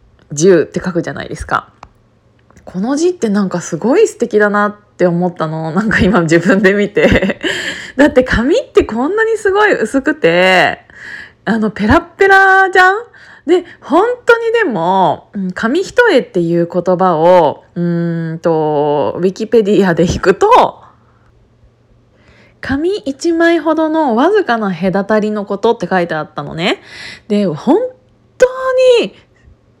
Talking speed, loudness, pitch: 255 characters per minute, -12 LUFS, 225 Hz